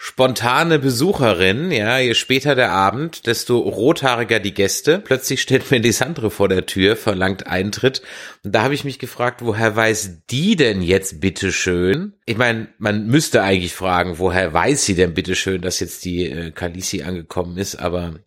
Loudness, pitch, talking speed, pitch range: -18 LUFS, 105 Hz, 170 wpm, 95-130 Hz